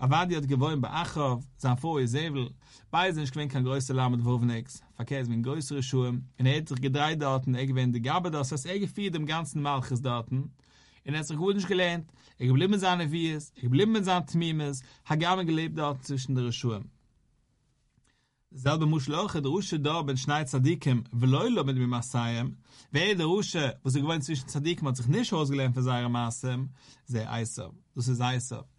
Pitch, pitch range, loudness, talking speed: 135 Hz, 125-155 Hz, -29 LUFS, 185 wpm